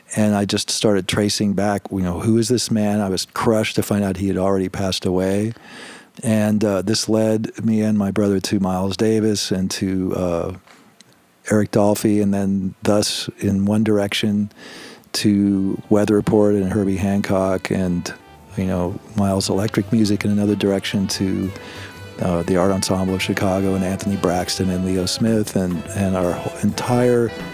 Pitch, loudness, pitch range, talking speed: 100 Hz, -19 LUFS, 95-105 Hz, 170 wpm